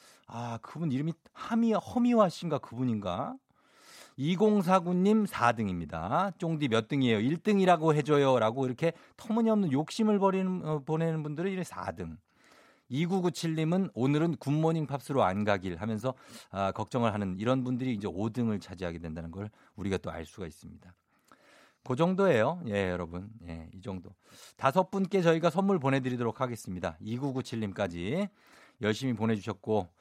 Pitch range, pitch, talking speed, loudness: 105-170 Hz, 130 Hz, 320 characters per minute, -30 LUFS